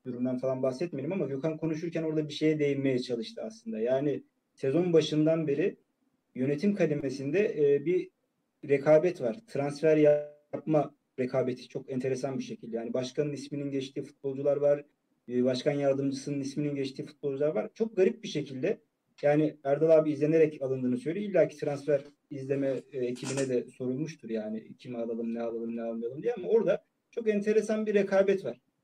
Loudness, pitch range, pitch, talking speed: -30 LUFS, 130-165 Hz, 145 Hz, 150 wpm